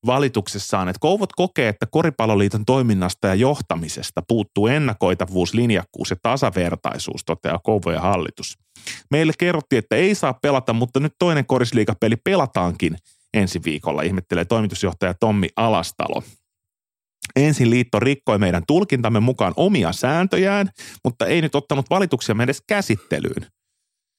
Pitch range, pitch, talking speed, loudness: 95-135 Hz, 110 Hz, 120 wpm, -20 LUFS